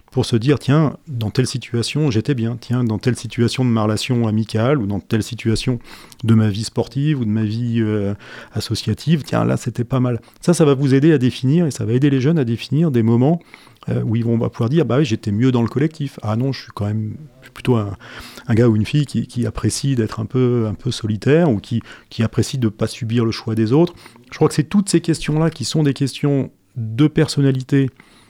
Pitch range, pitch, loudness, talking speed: 110-140 Hz, 120 Hz, -18 LUFS, 240 wpm